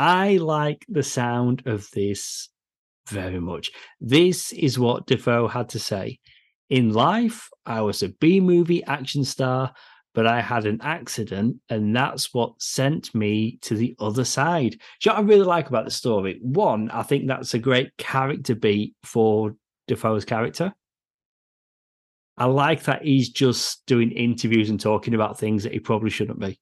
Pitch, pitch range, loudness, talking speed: 120 Hz, 110-140 Hz, -22 LUFS, 170 wpm